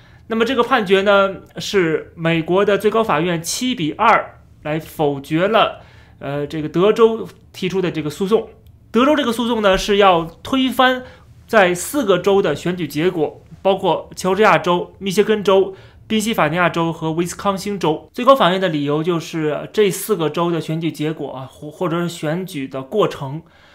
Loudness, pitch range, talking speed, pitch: -18 LUFS, 155-210 Hz, 265 characters per minute, 180 Hz